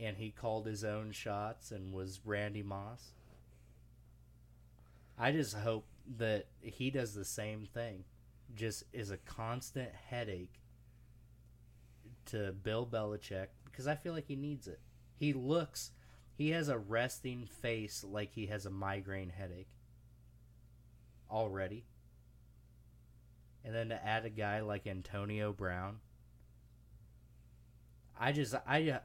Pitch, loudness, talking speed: 100 Hz, -41 LUFS, 125 wpm